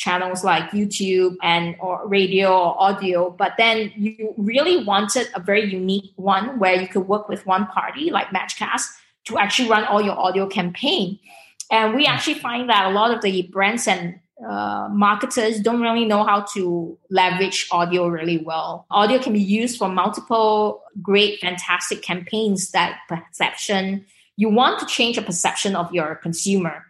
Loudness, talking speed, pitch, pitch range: -20 LUFS, 165 wpm, 195 Hz, 180-215 Hz